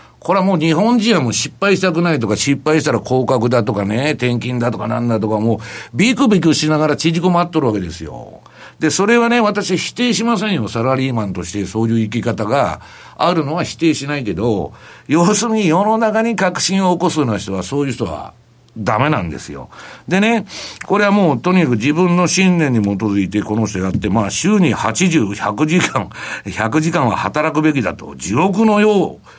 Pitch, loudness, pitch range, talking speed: 155 Hz, -15 LUFS, 115-185 Hz, 375 characters per minute